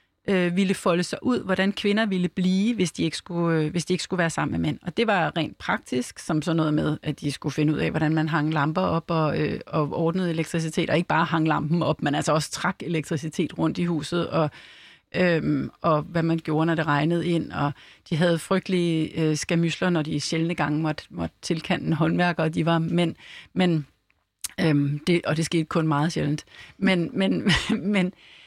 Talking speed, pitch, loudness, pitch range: 205 wpm, 165 Hz, -24 LUFS, 155-180 Hz